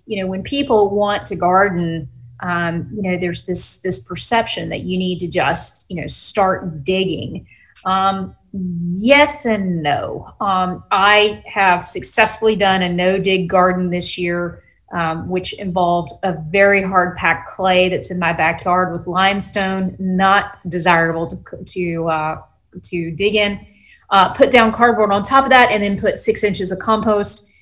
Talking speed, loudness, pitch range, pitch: 165 wpm, -16 LUFS, 175-205 Hz, 185 Hz